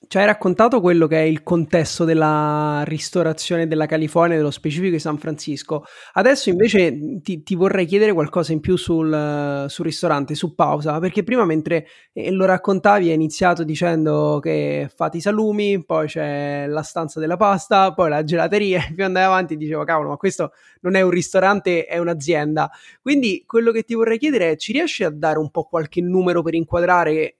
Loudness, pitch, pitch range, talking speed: -19 LUFS, 170 Hz, 155-190 Hz, 180 wpm